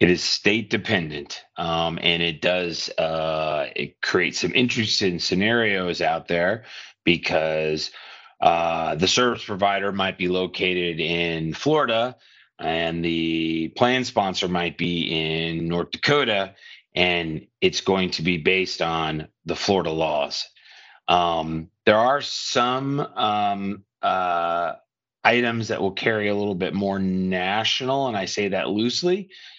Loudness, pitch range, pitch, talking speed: -22 LUFS, 85-105 Hz, 90 Hz, 130 wpm